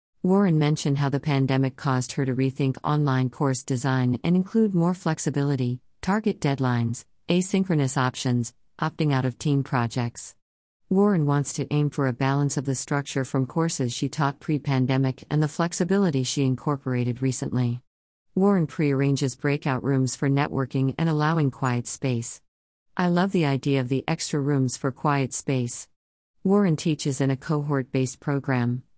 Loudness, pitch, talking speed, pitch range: -25 LUFS, 140 Hz, 155 wpm, 130-150 Hz